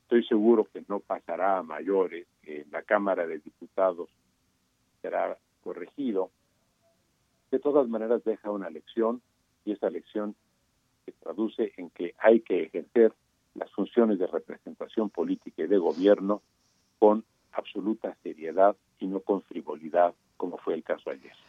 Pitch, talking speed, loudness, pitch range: 110 Hz, 140 wpm, -28 LUFS, 100-115 Hz